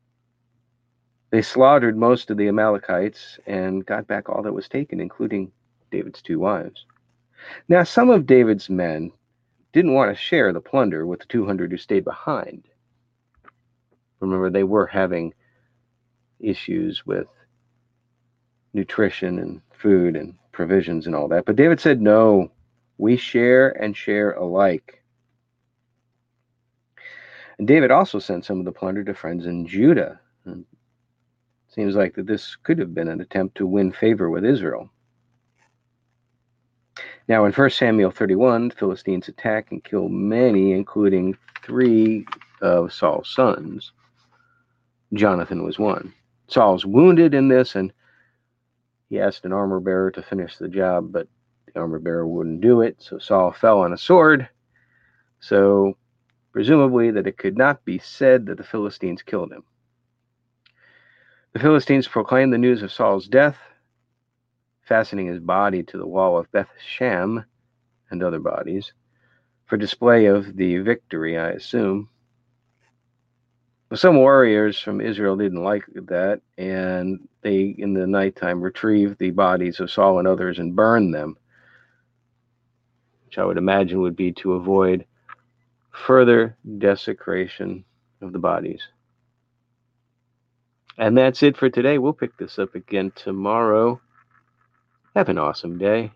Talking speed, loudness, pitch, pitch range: 135 wpm, -19 LUFS, 120 Hz, 95-120 Hz